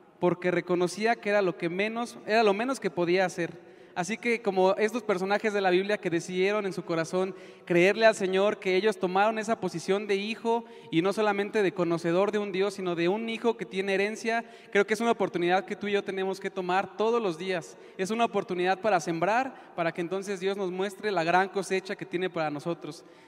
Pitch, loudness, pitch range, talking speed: 190 Hz, -28 LUFS, 180-210 Hz, 215 wpm